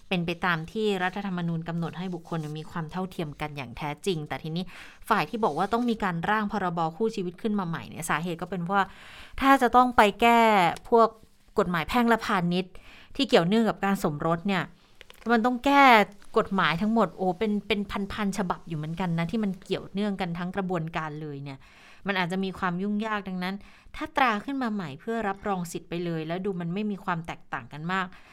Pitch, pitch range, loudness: 190 Hz, 170-215 Hz, -27 LUFS